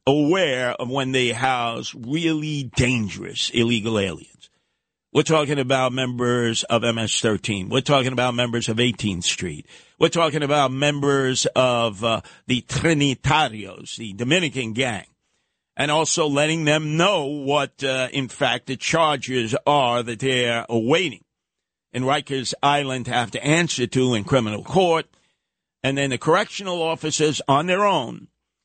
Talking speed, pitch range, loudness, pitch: 140 wpm, 120-145 Hz, -21 LUFS, 130 Hz